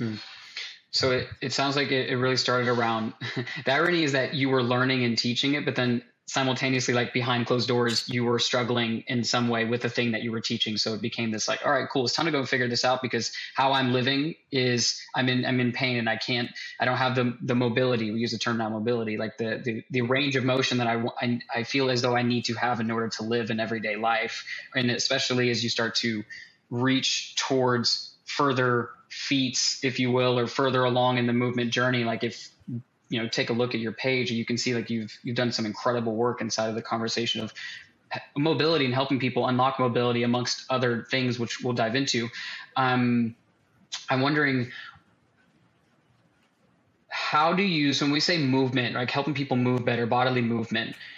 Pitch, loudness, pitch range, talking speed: 125 Hz, -26 LUFS, 115-130 Hz, 215 wpm